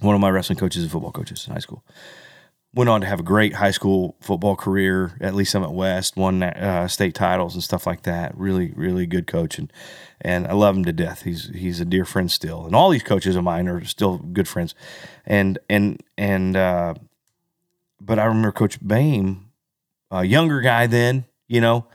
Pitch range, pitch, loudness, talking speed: 90-115 Hz, 95 Hz, -21 LUFS, 210 wpm